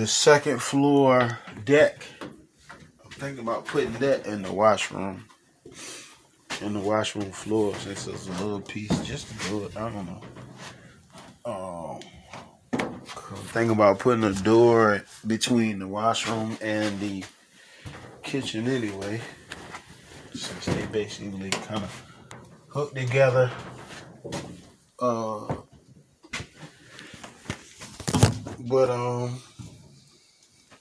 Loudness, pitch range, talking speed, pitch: -25 LUFS, 105-125 Hz, 100 wpm, 110 Hz